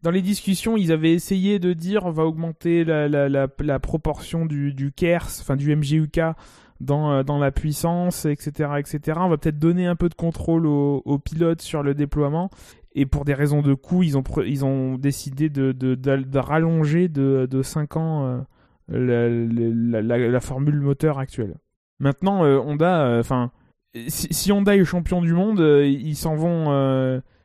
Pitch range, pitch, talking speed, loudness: 135-165 Hz, 150 Hz, 190 wpm, -21 LUFS